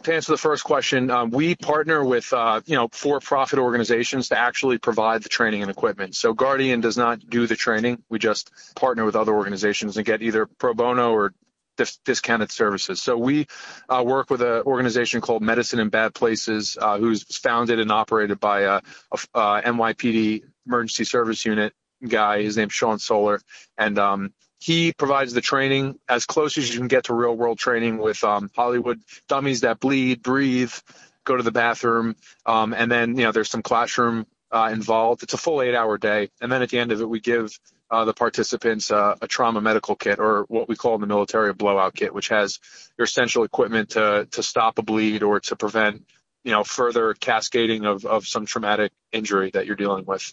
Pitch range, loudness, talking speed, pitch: 110-125 Hz, -22 LUFS, 200 wpm, 115 Hz